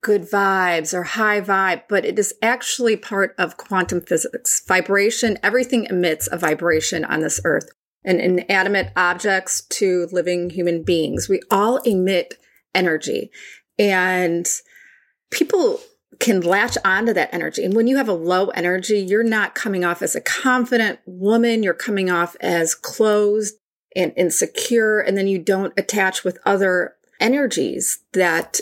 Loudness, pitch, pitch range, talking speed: -19 LUFS, 195 Hz, 180-225 Hz, 150 wpm